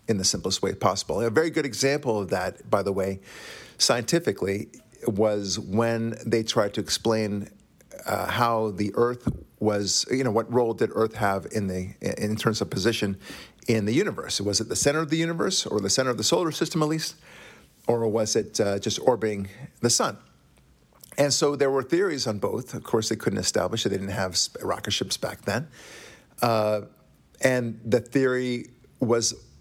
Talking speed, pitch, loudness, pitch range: 185 wpm, 115 Hz, -25 LUFS, 100-125 Hz